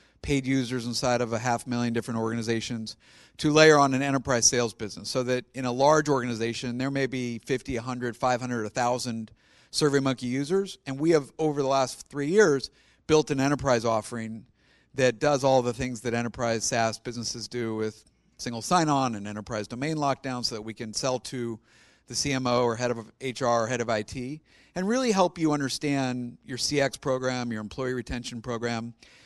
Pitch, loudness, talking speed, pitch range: 125 Hz, -27 LUFS, 185 wpm, 115-135 Hz